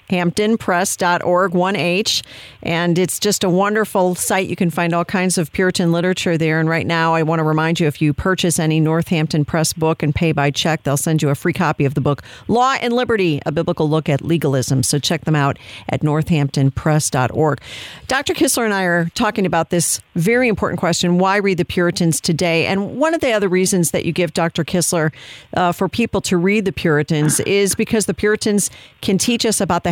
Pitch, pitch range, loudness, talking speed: 175 Hz, 155-195 Hz, -17 LUFS, 205 wpm